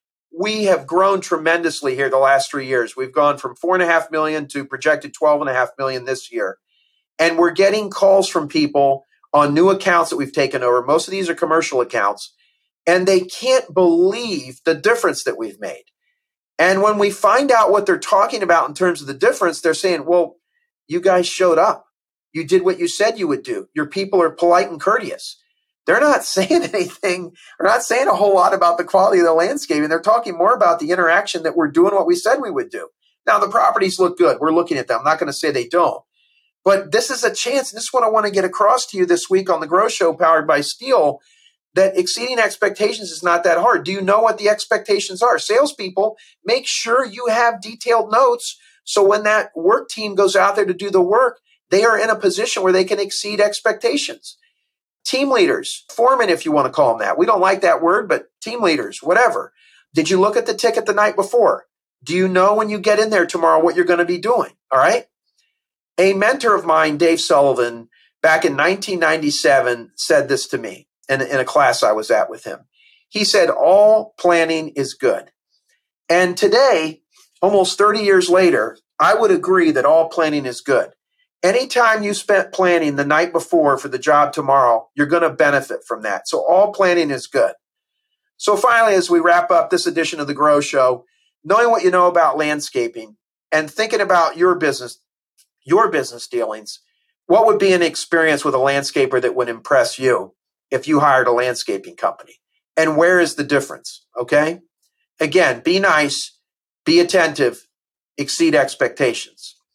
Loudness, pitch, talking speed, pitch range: -16 LUFS, 185 Hz, 200 wpm, 160-230 Hz